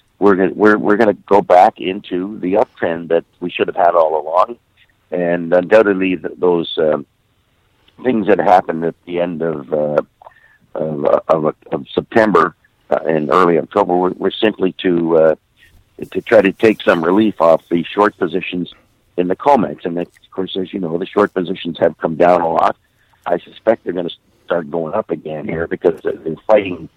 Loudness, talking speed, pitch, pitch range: -16 LUFS, 190 wpm, 90 Hz, 85-100 Hz